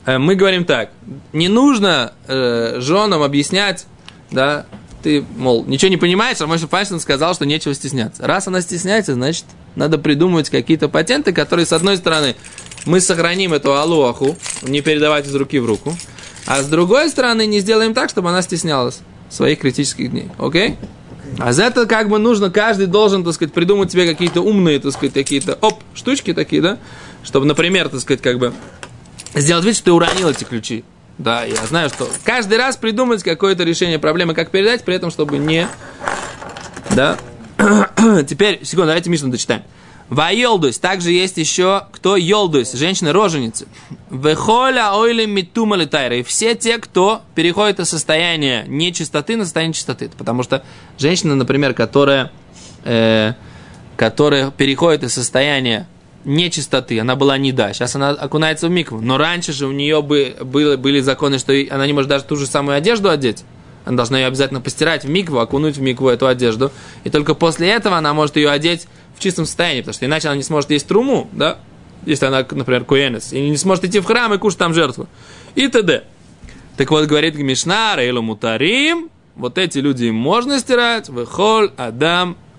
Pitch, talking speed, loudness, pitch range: 155 Hz, 170 wpm, -15 LUFS, 135-185 Hz